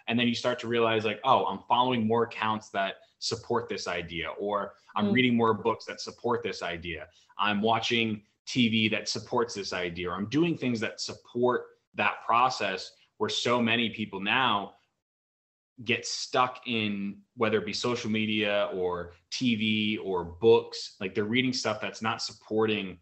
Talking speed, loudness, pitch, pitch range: 165 wpm, -28 LUFS, 110 Hz, 100-120 Hz